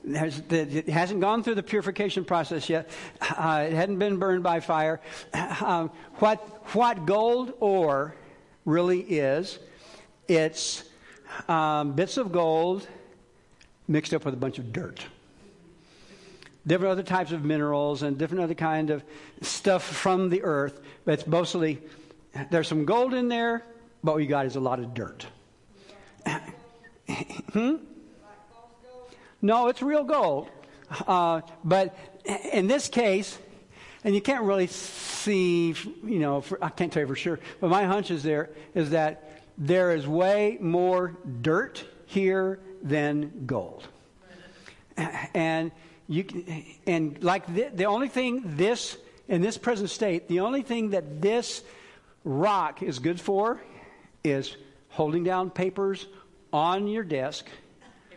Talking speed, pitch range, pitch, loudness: 140 wpm, 155-200 Hz, 175 Hz, -27 LUFS